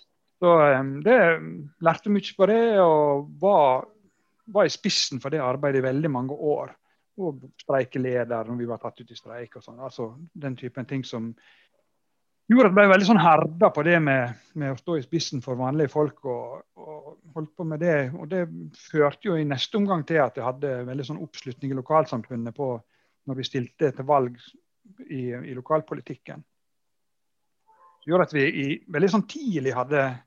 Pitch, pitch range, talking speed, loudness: 145 Hz, 130-170 Hz, 180 wpm, -23 LUFS